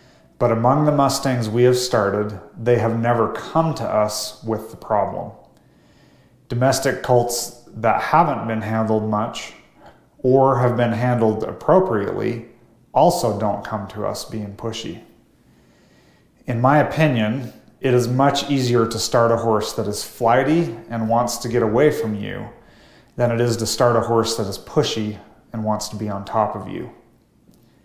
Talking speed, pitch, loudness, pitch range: 160 wpm, 115 Hz, -20 LUFS, 110-125 Hz